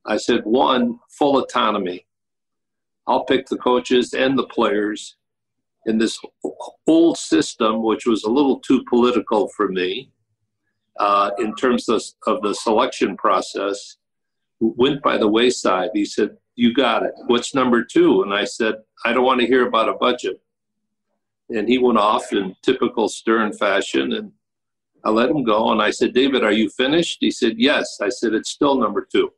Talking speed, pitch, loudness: 170 wpm, 120 Hz, -19 LUFS